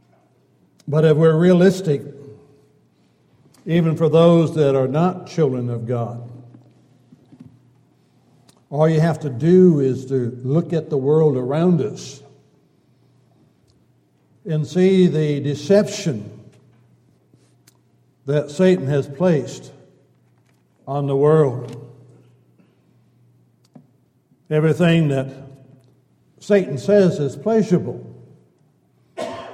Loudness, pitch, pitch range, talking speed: -18 LUFS, 145 Hz, 125-165 Hz, 85 wpm